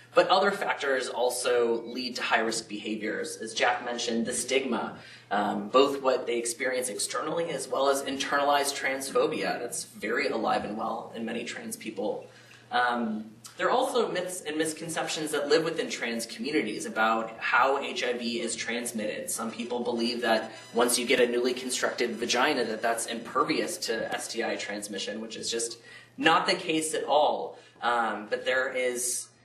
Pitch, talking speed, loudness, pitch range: 120 Hz, 165 wpm, -28 LUFS, 115-135 Hz